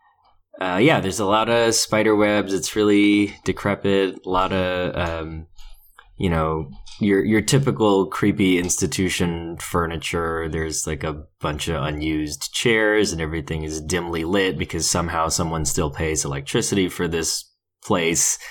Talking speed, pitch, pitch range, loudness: 145 wpm, 90 Hz, 80-100 Hz, -21 LUFS